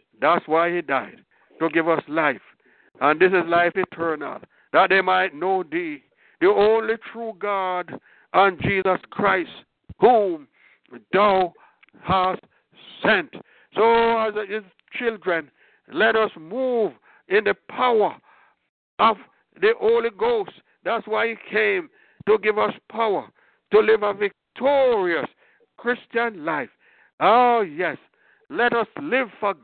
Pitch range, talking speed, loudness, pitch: 185-260 Hz, 130 wpm, -21 LUFS, 220 Hz